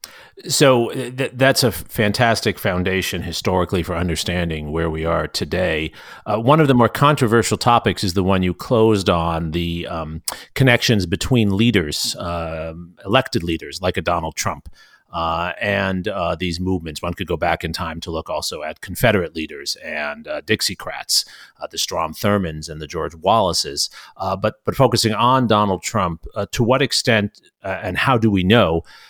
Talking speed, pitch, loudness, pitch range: 170 wpm, 95 Hz, -19 LUFS, 85-115 Hz